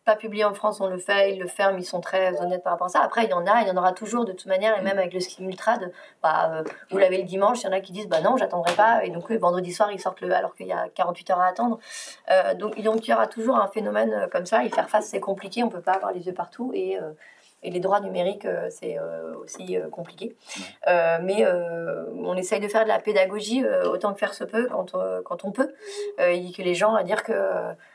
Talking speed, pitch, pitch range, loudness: 270 wpm, 190 Hz, 180-215 Hz, -24 LUFS